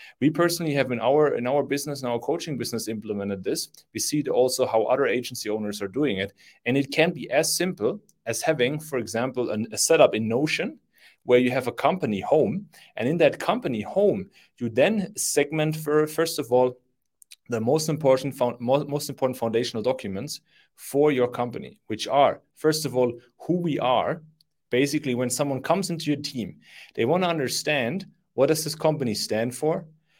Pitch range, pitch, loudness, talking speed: 120-155 Hz, 140 Hz, -25 LUFS, 185 wpm